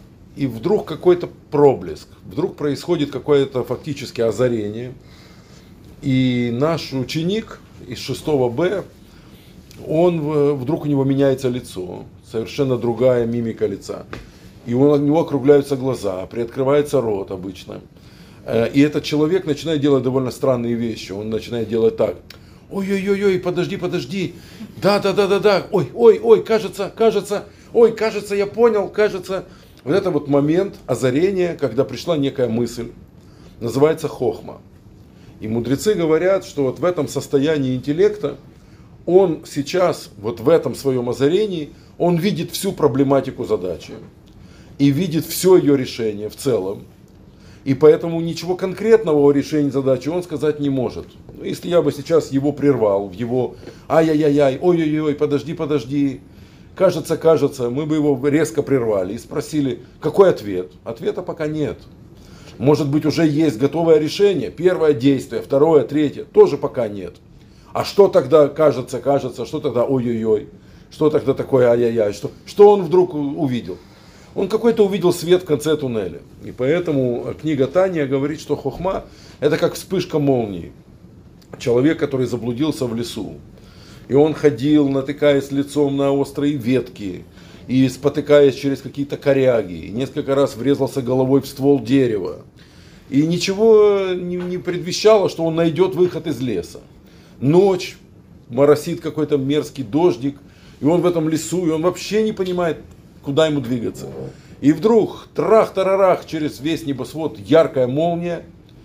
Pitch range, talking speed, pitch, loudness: 130-170 Hz, 135 wpm, 145 Hz, -18 LUFS